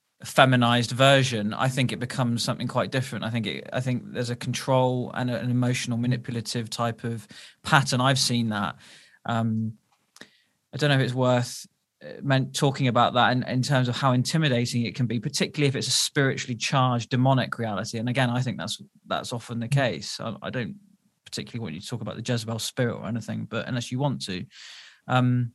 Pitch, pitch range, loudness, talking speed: 125 Hz, 115-130 Hz, -25 LUFS, 195 wpm